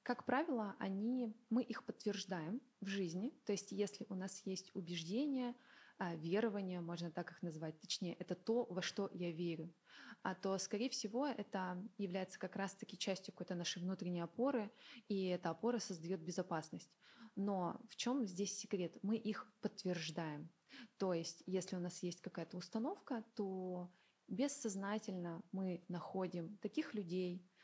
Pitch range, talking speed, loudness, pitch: 180-225 Hz, 145 wpm, -44 LUFS, 195 Hz